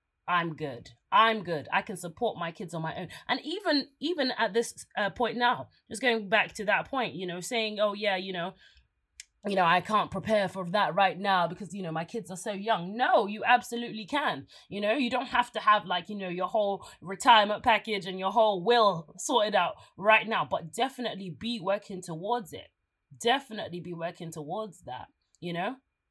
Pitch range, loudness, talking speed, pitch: 180-230 Hz, -28 LUFS, 205 wpm, 205 Hz